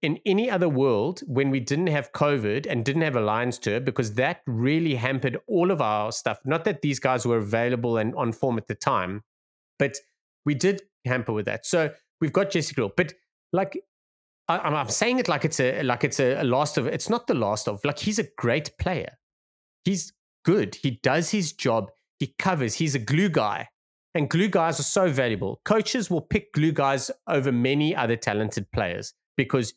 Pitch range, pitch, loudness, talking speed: 125-180 Hz, 140 Hz, -25 LUFS, 200 wpm